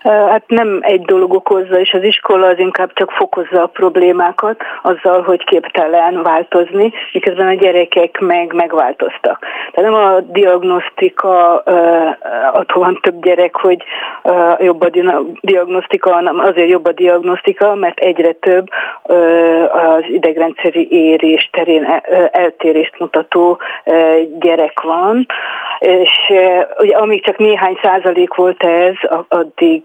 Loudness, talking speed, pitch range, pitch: -11 LUFS, 120 wpm, 170-195 Hz, 180 Hz